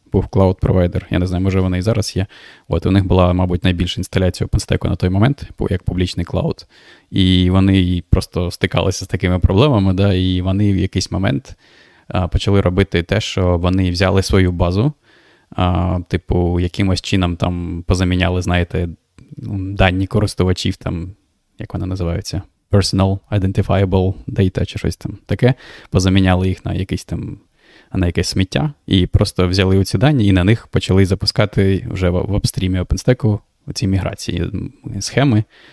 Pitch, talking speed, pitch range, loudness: 95 Hz, 160 wpm, 90-105 Hz, -17 LUFS